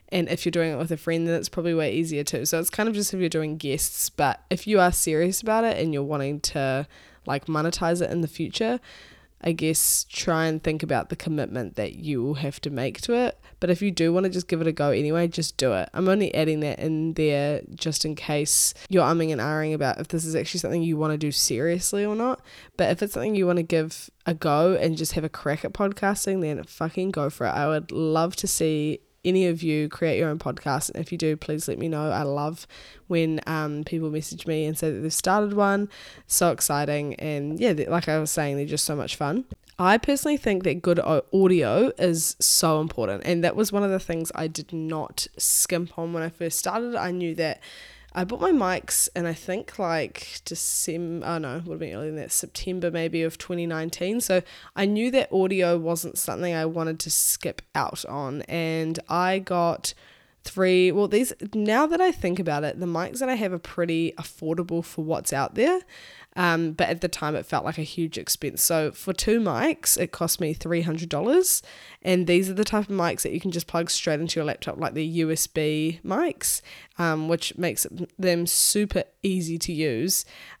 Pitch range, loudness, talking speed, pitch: 155-180 Hz, -25 LUFS, 225 wpm, 165 Hz